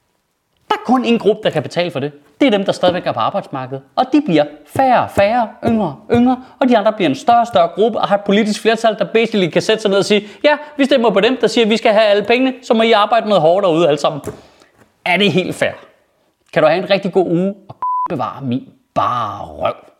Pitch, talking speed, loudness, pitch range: 210 Hz, 245 wpm, -15 LUFS, 185-235 Hz